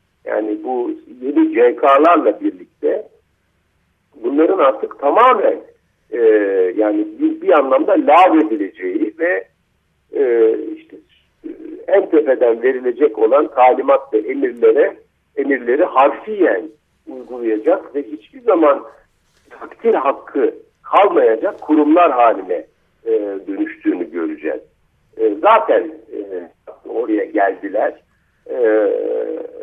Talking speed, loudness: 90 wpm, -15 LUFS